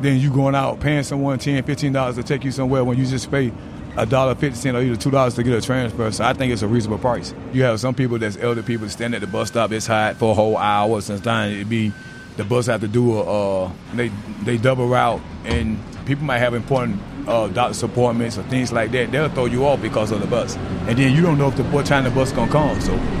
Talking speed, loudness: 260 wpm, -20 LUFS